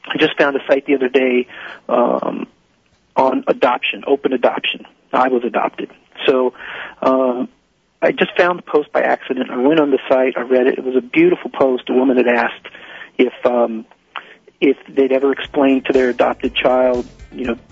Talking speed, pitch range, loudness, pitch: 185 wpm, 125-140 Hz, -16 LUFS, 130 Hz